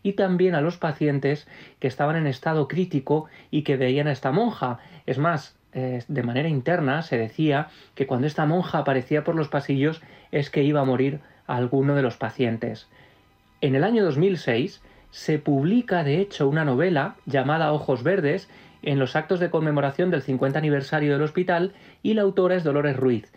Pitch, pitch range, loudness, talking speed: 145 Hz, 135-165 Hz, -24 LUFS, 180 wpm